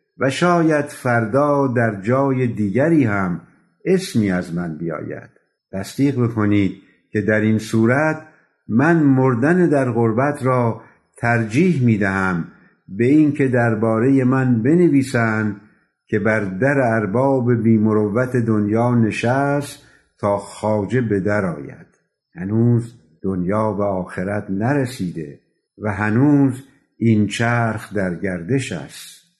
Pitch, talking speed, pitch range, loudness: 115 Hz, 110 wpm, 105-135 Hz, -18 LUFS